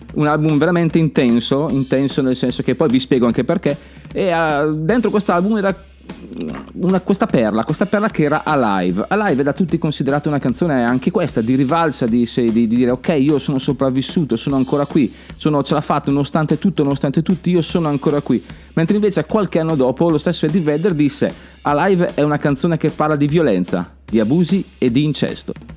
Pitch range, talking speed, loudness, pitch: 135-175 Hz, 195 wpm, -17 LUFS, 150 Hz